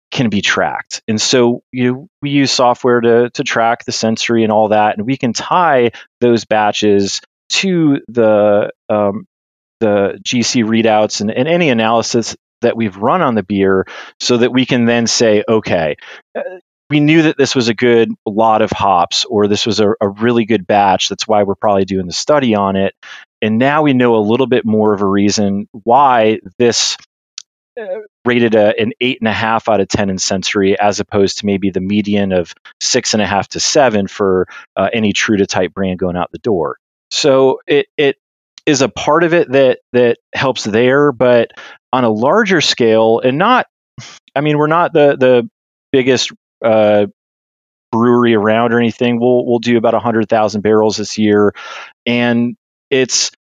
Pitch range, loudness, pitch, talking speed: 105-125 Hz, -13 LUFS, 115 Hz, 185 wpm